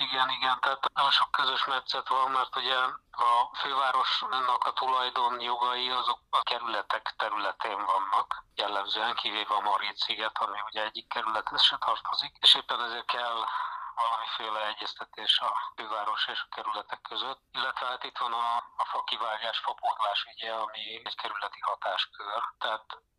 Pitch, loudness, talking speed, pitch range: 125 Hz, -29 LUFS, 150 wpm, 115-130 Hz